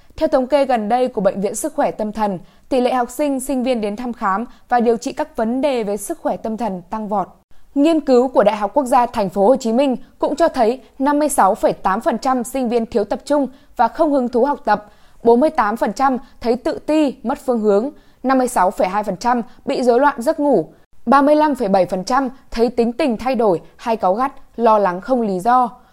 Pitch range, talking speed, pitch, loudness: 220-275 Hz, 205 wpm, 245 Hz, -18 LUFS